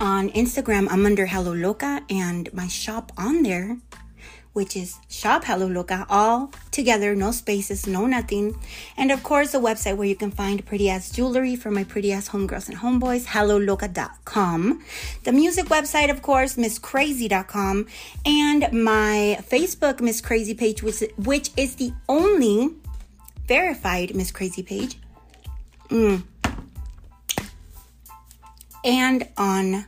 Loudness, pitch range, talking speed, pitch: -22 LUFS, 195-255 Hz, 130 wpm, 210 Hz